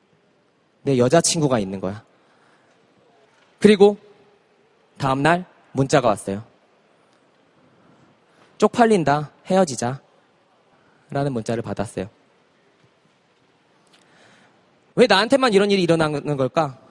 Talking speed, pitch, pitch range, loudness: 190 characters per minute, 145 Hz, 125-195 Hz, -19 LUFS